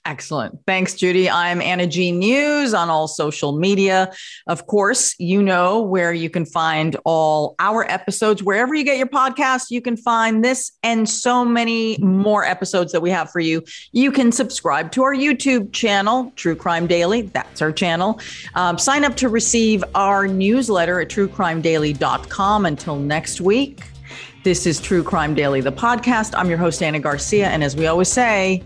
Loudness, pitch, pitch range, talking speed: -18 LUFS, 190 Hz, 170-230 Hz, 175 wpm